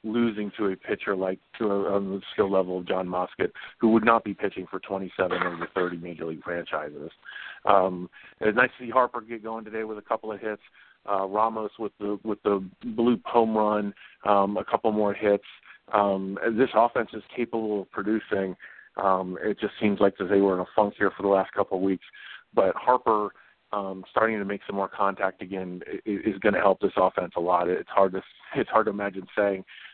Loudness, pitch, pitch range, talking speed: -26 LUFS, 100 Hz, 95-110 Hz, 210 wpm